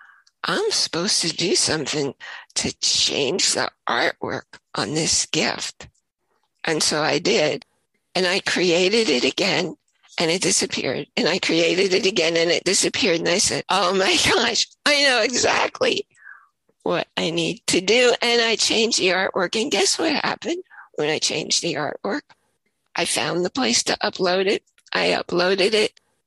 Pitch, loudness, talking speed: 225 Hz, -20 LUFS, 160 wpm